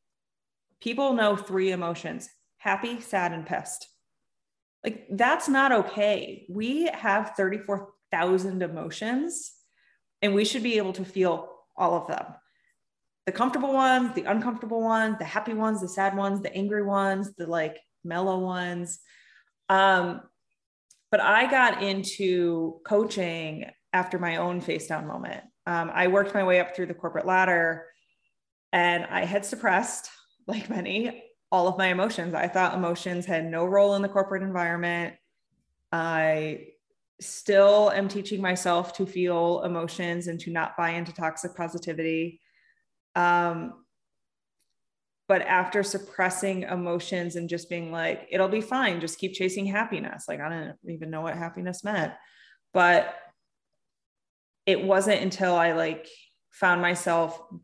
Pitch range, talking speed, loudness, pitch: 170-205 Hz, 140 wpm, -26 LUFS, 185 Hz